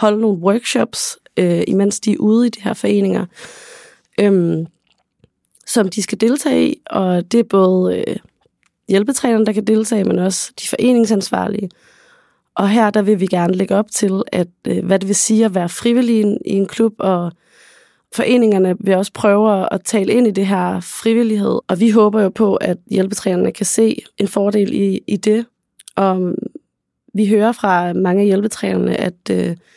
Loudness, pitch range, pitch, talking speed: -16 LUFS, 190-225 Hz, 205 Hz, 175 wpm